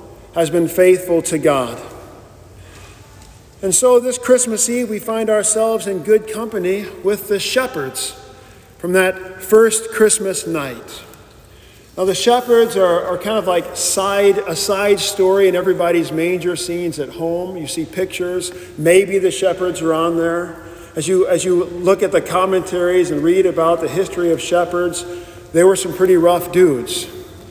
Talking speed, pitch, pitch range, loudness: 155 wpm, 185 Hz, 170-200 Hz, -16 LUFS